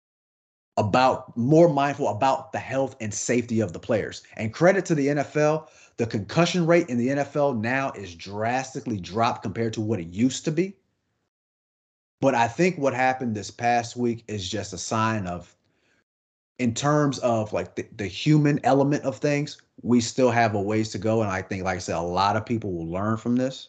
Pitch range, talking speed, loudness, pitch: 105-140 Hz, 195 wpm, -24 LUFS, 120 Hz